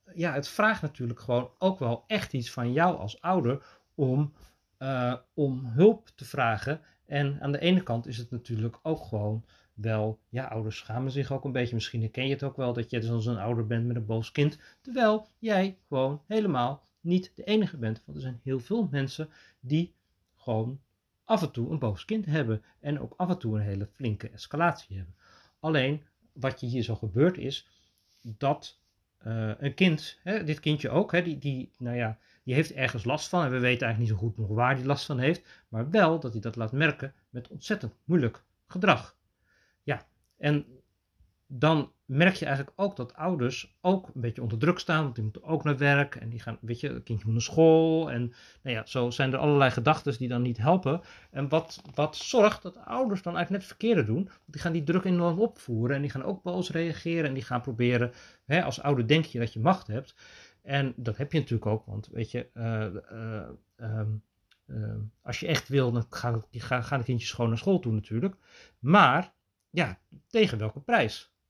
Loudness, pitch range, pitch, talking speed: -29 LUFS, 115-160 Hz, 130 Hz, 210 wpm